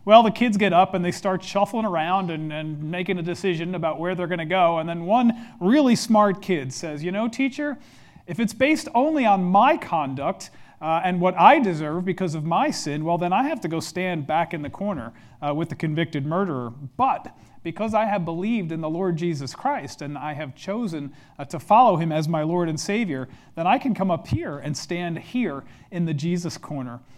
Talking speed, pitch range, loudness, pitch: 220 wpm, 155-200 Hz, -23 LUFS, 175 Hz